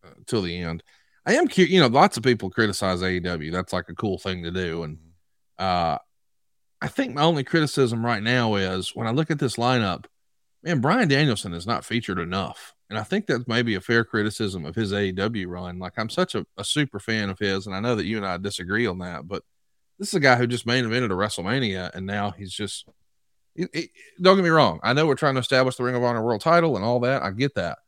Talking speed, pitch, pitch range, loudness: 245 wpm, 110 Hz, 95-125 Hz, -23 LUFS